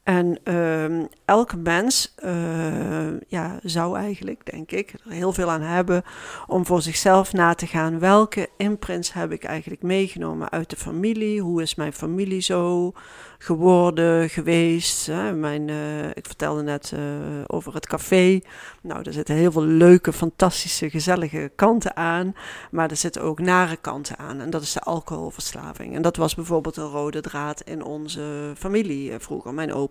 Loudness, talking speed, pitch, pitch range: -22 LUFS, 165 wpm, 165 Hz, 155-180 Hz